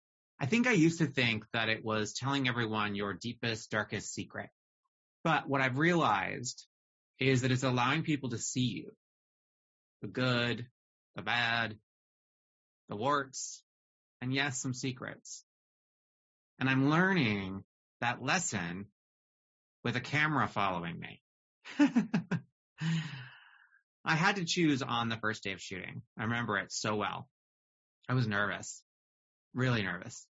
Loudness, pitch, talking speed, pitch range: -32 LUFS, 120 Hz, 130 wpm, 105-140 Hz